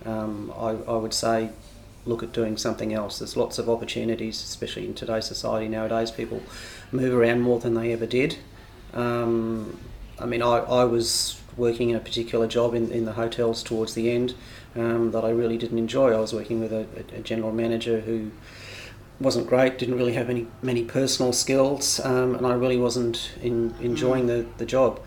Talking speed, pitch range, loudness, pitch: 190 wpm, 115-120 Hz, -25 LUFS, 115 Hz